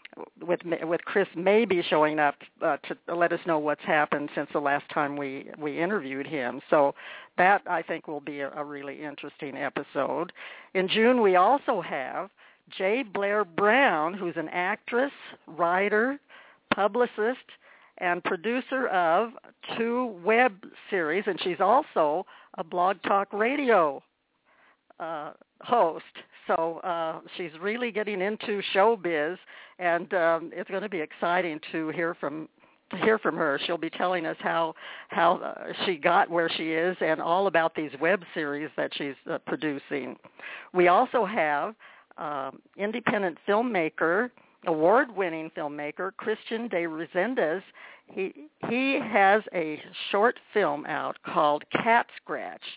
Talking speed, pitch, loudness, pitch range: 140 wpm, 180 Hz, -27 LUFS, 160-215 Hz